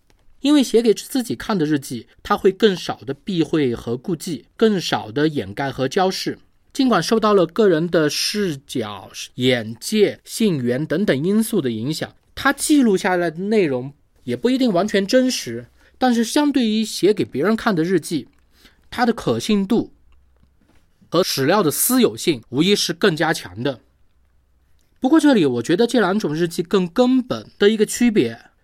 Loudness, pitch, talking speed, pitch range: -19 LUFS, 185 Hz, 245 characters per minute, 135-225 Hz